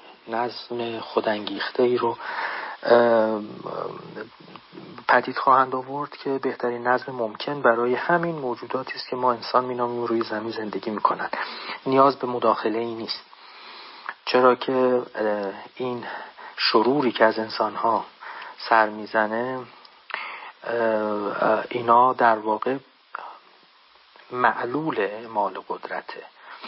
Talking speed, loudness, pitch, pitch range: 100 wpm, -23 LUFS, 120 Hz, 110-125 Hz